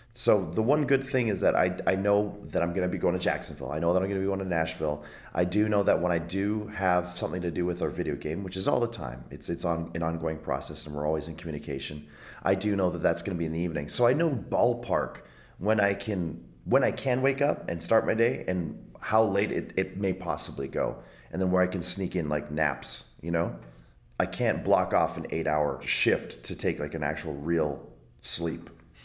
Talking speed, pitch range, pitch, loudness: 250 wpm, 75-100 Hz, 85 Hz, -28 LUFS